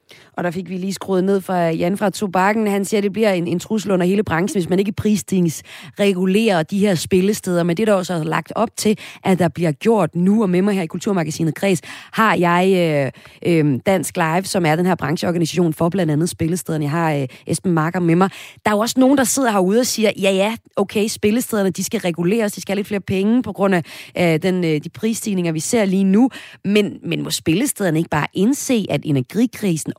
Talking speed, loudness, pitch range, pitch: 230 wpm, -18 LUFS, 170-210 Hz, 190 Hz